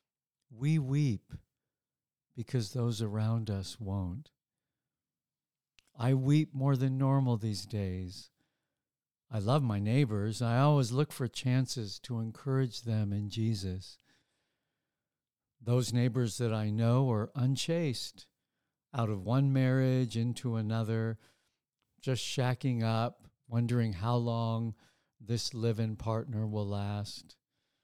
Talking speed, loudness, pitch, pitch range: 115 wpm, -32 LUFS, 120 Hz, 110-130 Hz